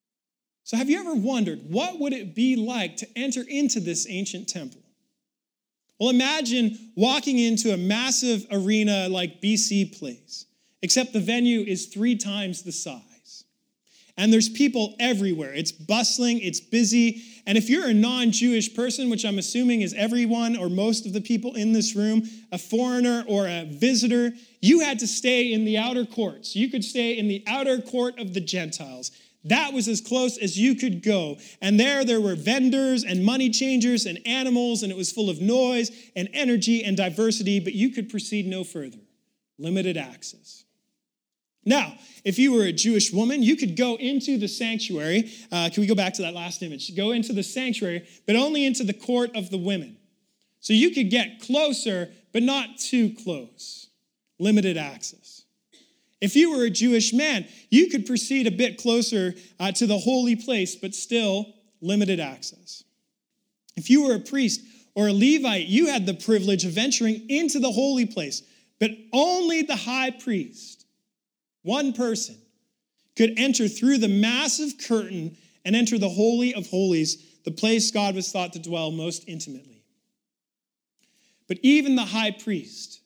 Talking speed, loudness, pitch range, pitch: 170 wpm, -23 LUFS, 200-250 Hz, 225 Hz